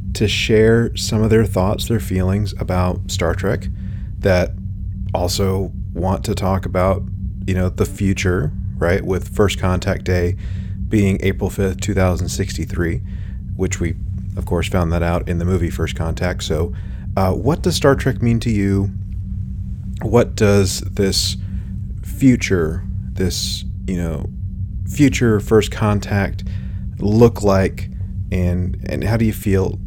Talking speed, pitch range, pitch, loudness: 145 wpm, 95-100 Hz, 95 Hz, -19 LUFS